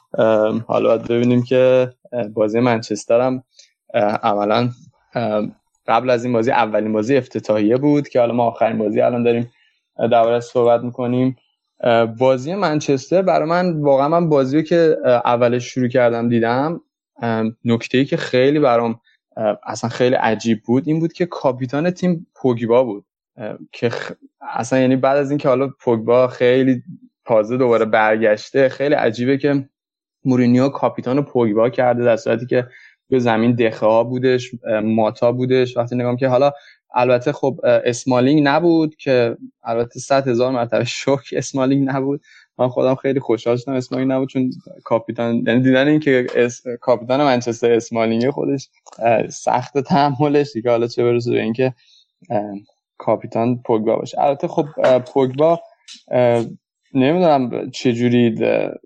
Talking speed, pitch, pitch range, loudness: 135 wpm, 125 Hz, 115-140 Hz, -17 LUFS